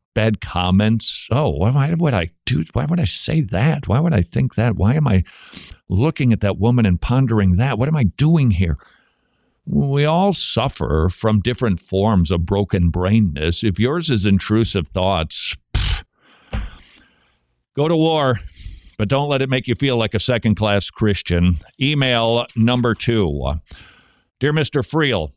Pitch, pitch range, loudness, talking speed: 110 Hz, 90-130 Hz, -18 LUFS, 160 wpm